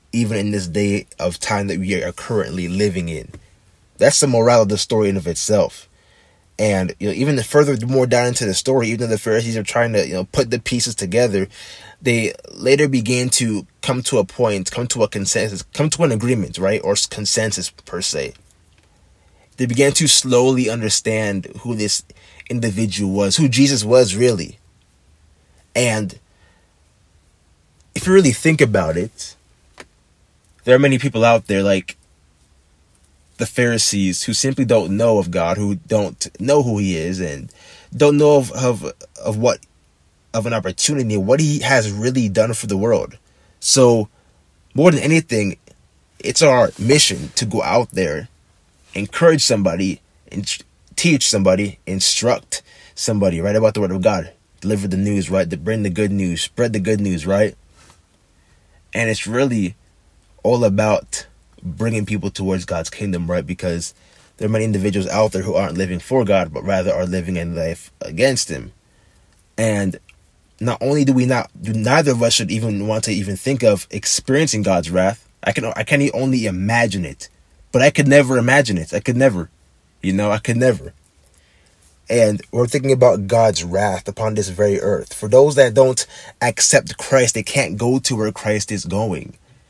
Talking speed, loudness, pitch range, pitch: 175 wpm, -17 LUFS, 90-120 Hz, 105 Hz